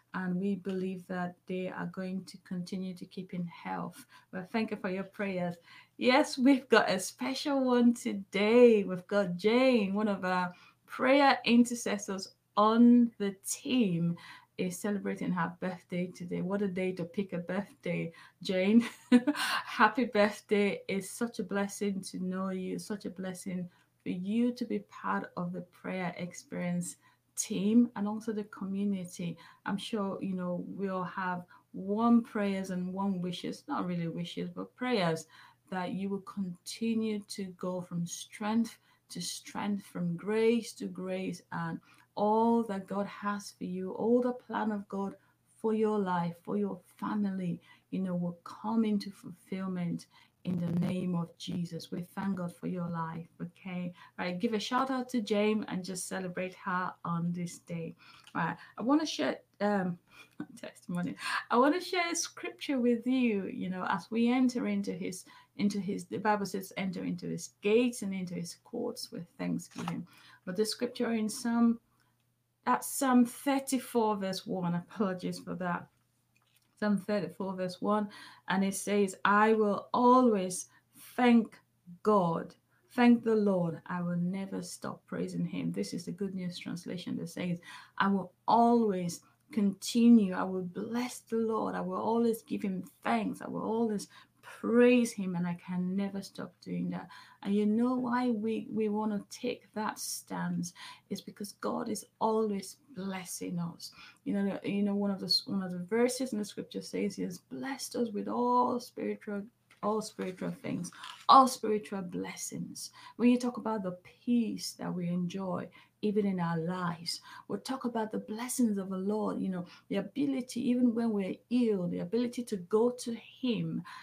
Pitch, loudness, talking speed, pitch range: 200 Hz, -32 LUFS, 170 wpm, 180-230 Hz